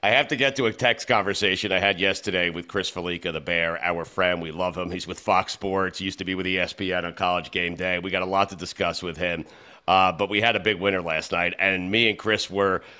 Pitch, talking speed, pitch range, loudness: 95 Hz, 265 wpm, 90-100 Hz, -24 LUFS